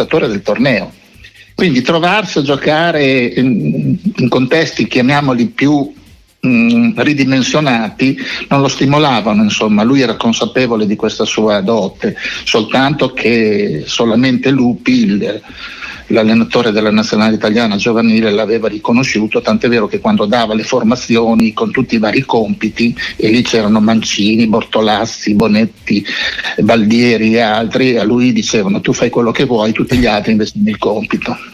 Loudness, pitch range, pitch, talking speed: -12 LUFS, 110-145 Hz, 125 Hz, 135 wpm